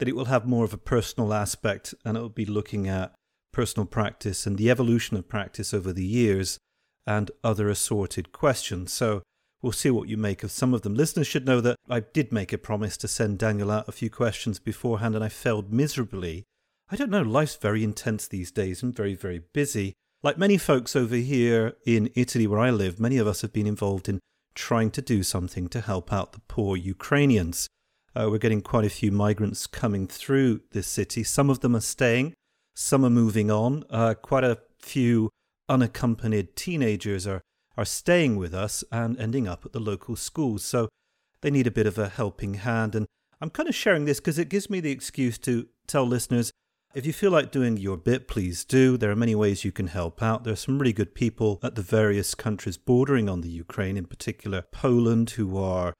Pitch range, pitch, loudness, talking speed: 100-125 Hz, 110 Hz, -26 LUFS, 210 wpm